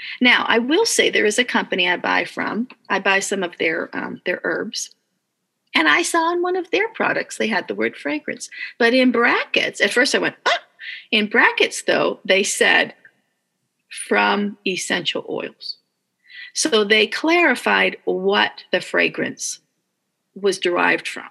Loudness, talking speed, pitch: -18 LUFS, 160 wpm, 245 Hz